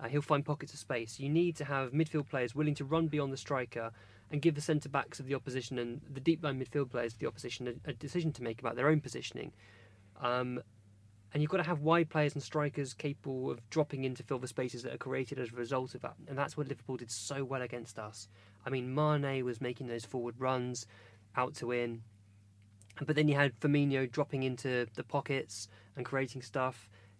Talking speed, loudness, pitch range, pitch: 225 wpm, -36 LUFS, 120-145 Hz, 130 Hz